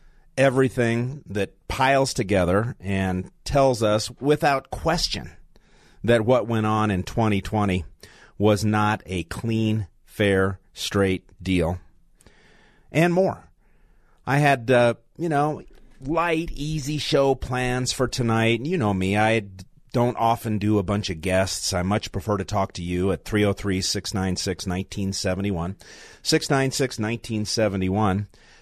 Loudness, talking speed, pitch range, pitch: -23 LUFS, 125 wpm, 95-125 Hz, 105 Hz